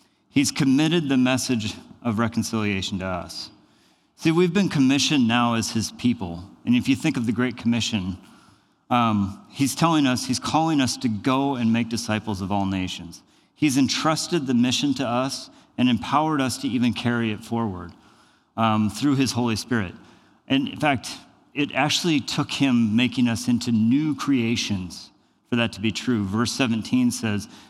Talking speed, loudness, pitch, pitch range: 170 wpm, -23 LUFS, 120 Hz, 110-135 Hz